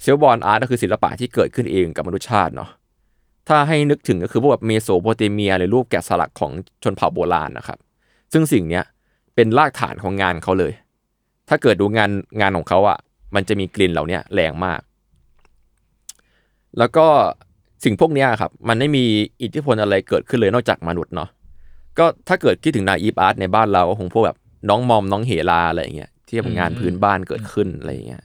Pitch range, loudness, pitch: 90-115 Hz, -18 LUFS, 100 Hz